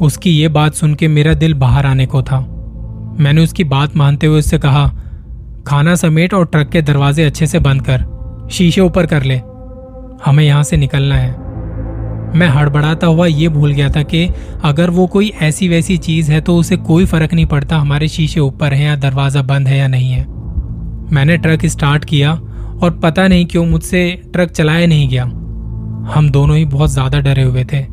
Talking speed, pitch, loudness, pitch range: 190 wpm, 150 Hz, -12 LUFS, 135-165 Hz